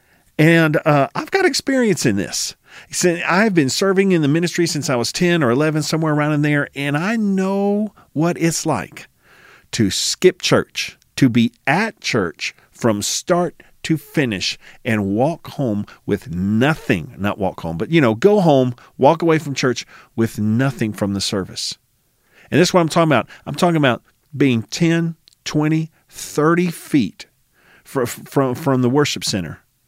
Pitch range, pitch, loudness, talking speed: 125-170 Hz, 150 Hz, -18 LUFS, 165 wpm